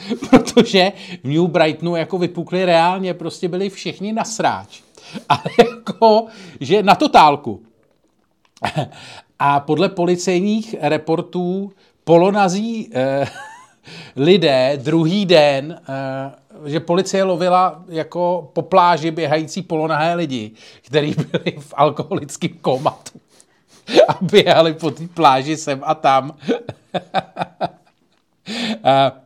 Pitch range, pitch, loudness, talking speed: 150-190 Hz, 170 Hz, -17 LUFS, 105 wpm